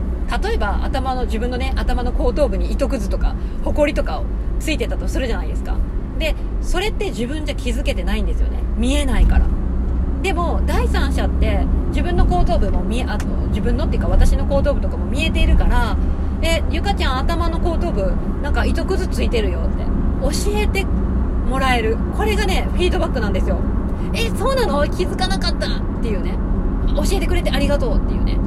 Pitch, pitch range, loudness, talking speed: 70 Hz, 65-80 Hz, -20 LUFS, 390 characters per minute